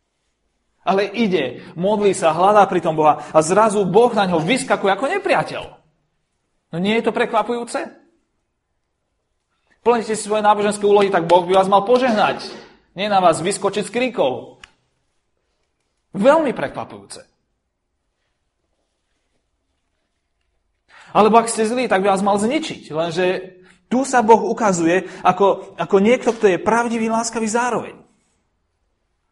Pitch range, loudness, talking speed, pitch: 185-230 Hz, -17 LUFS, 125 wpm, 205 Hz